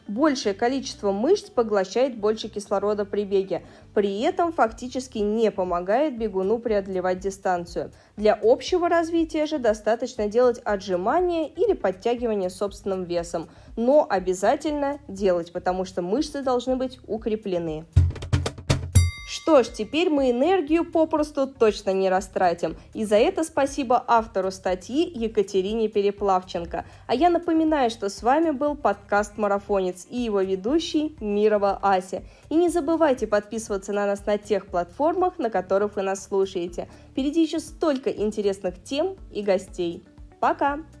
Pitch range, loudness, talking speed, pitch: 190-285 Hz, -24 LUFS, 130 wpm, 215 Hz